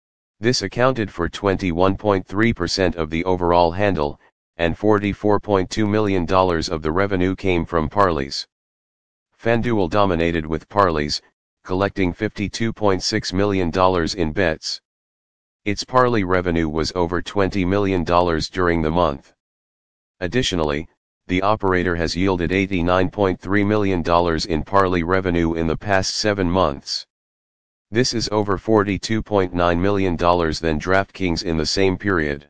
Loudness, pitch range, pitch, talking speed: -20 LUFS, 85-100 Hz, 95 Hz, 115 wpm